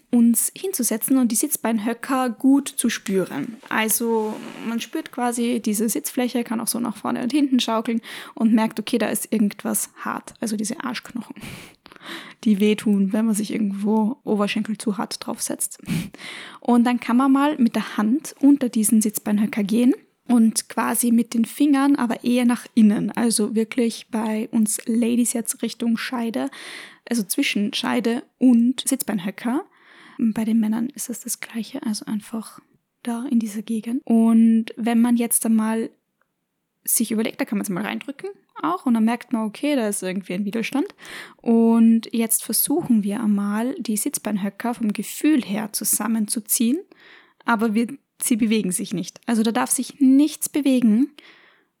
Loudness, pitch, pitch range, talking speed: -21 LUFS, 235 Hz, 220-255 Hz, 160 wpm